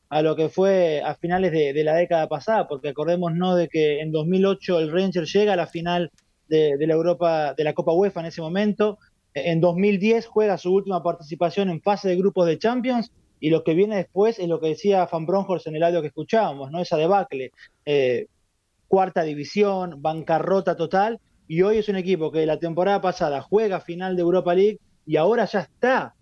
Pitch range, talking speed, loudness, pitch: 160-195 Hz, 205 wpm, -22 LUFS, 175 Hz